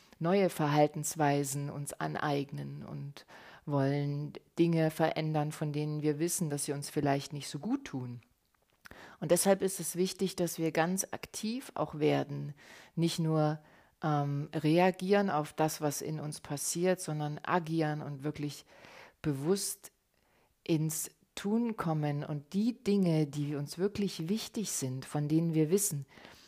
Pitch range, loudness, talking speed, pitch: 145-175 Hz, -33 LUFS, 140 wpm, 155 Hz